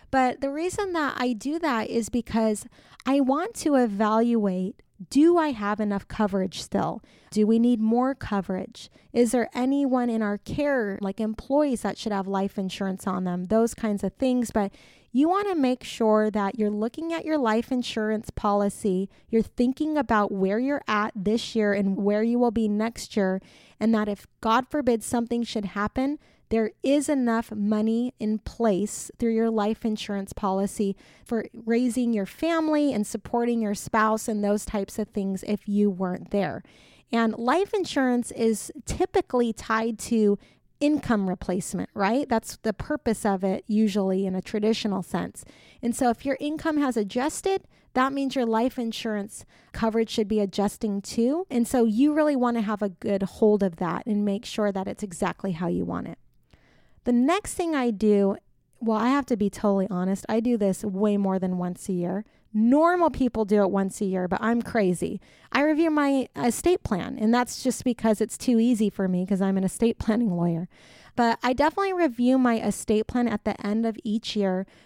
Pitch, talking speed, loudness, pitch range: 225 Hz, 185 wpm, -25 LUFS, 205-250 Hz